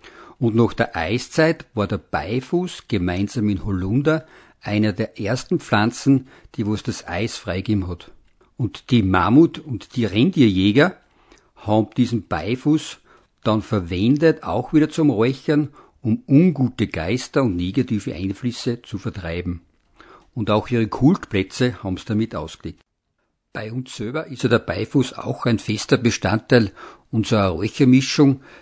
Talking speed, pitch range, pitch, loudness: 135 wpm, 105-135 Hz, 115 Hz, -20 LUFS